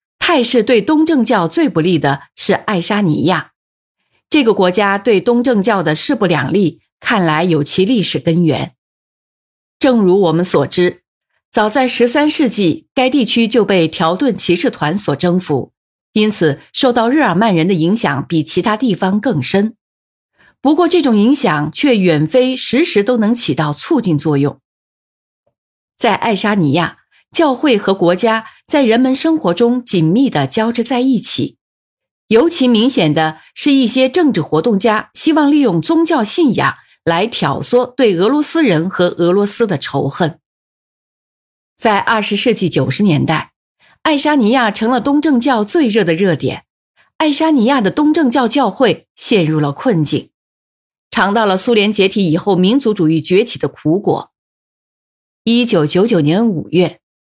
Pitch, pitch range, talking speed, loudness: 220 Hz, 175-260 Hz, 230 characters per minute, -13 LUFS